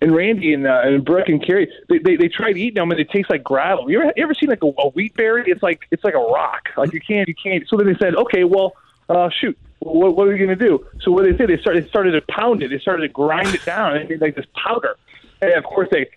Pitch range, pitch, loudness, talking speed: 160-225 Hz, 190 Hz, -17 LUFS, 295 wpm